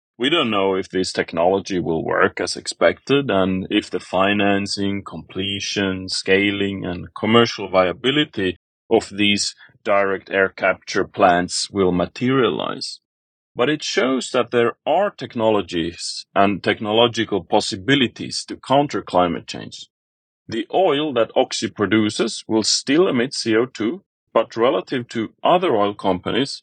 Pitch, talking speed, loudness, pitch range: 100 Hz, 125 wpm, -20 LUFS, 95-115 Hz